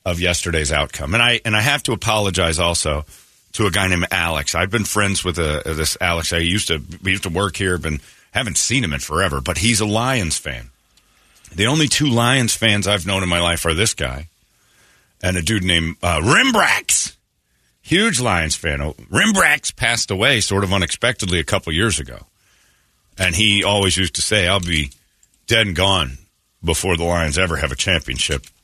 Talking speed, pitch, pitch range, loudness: 195 wpm, 95 Hz, 80-105 Hz, -17 LUFS